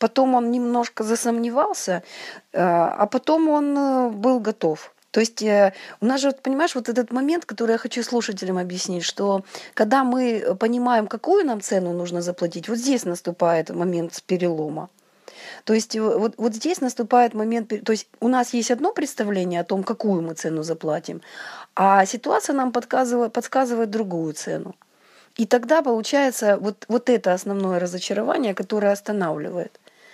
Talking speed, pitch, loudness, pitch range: 145 wpm, 225 Hz, -22 LUFS, 190-250 Hz